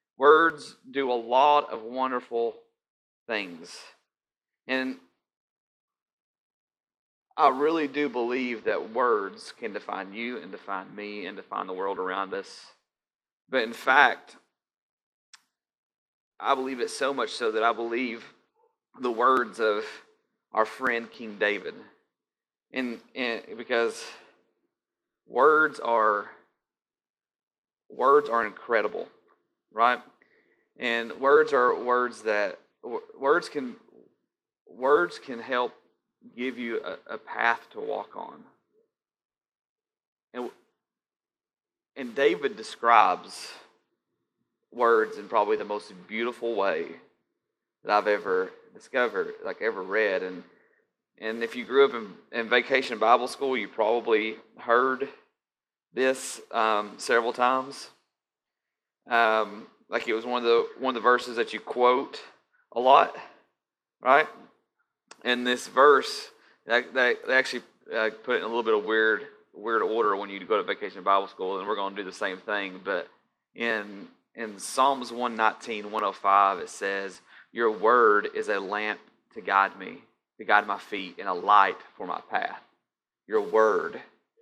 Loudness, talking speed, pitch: -26 LUFS, 130 wpm, 130 Hz